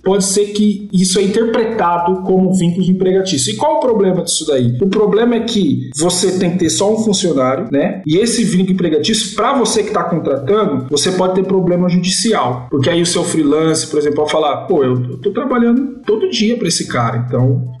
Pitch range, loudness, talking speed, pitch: 160-210 Hz, -14 LUFS, 210 wpm, 185 Hz